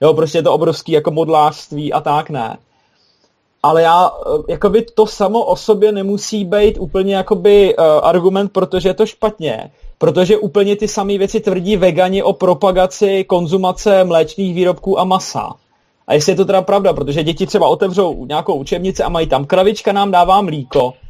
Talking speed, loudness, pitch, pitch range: 175 wpm, -14 LUFS, 190 Hz, 165-205 Hz